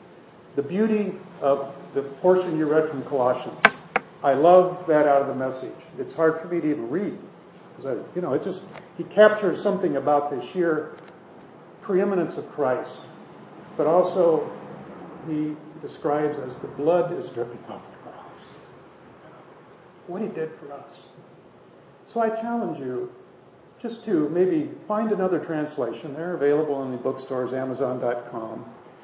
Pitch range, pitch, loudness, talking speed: 140-185 Hz, 160 Hz, -24 LUFS, 145 wpm